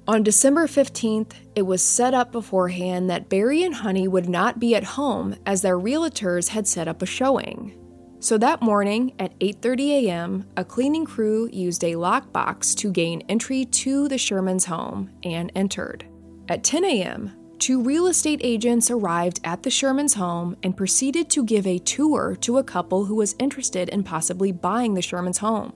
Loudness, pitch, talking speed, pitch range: -22 LUFS, 205 Hz, 175 wpm, 180-255 Hz